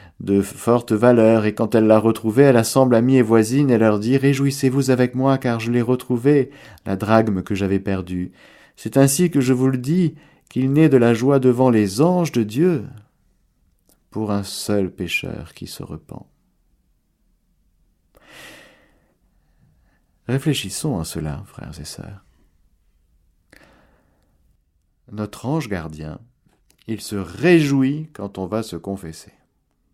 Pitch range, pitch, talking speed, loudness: 95-130 Hz, 110 Hz, 140 wpm, -18 LUFS